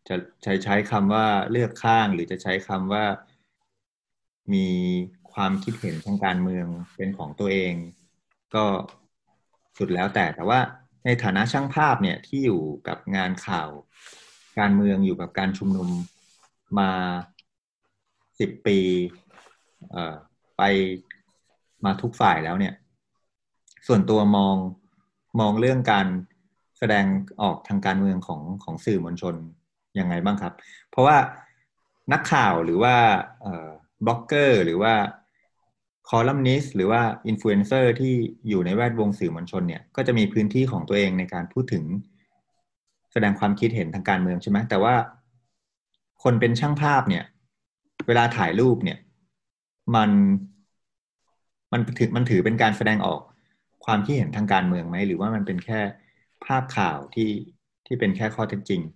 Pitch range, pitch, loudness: 95-120 Hz, 100 Hz, -23 LUFS